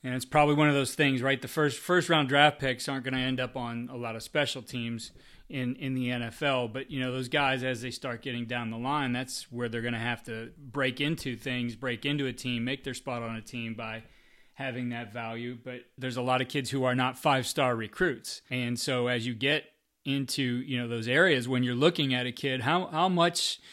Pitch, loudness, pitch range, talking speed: 130 Hz, -29 LUFS, 120-140 Hz, 240 wpm